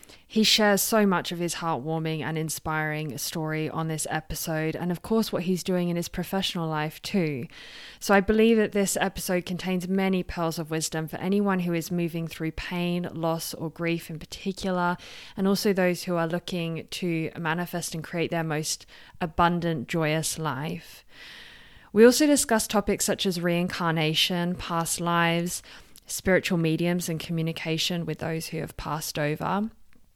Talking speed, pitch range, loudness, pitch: 160 wpm, 160-185 Hz, -26 LUFS, 170 Hz